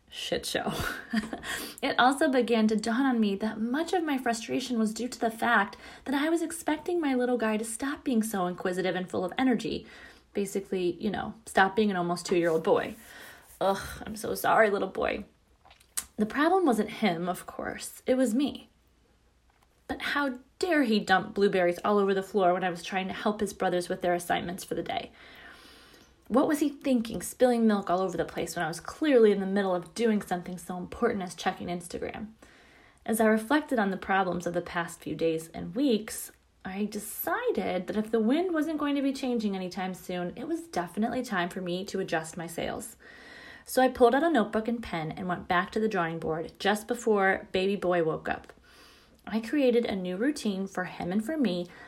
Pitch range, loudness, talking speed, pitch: 180-250 Hz, -29 LUFS, 200 wpm, 215 Hz